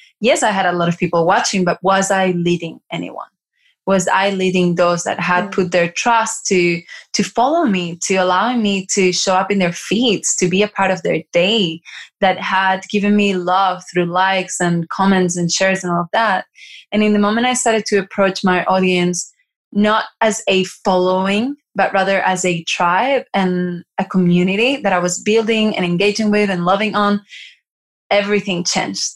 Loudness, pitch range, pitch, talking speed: -16 LUFS, 180-205 Hz, 190 Hz, 185 wpm